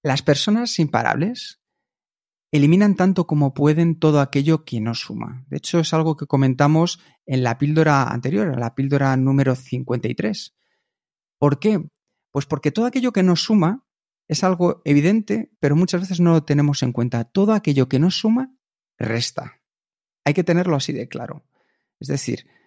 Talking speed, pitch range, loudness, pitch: 160 wpm, 135-180 Hz, -20 LUFS, 155 Hz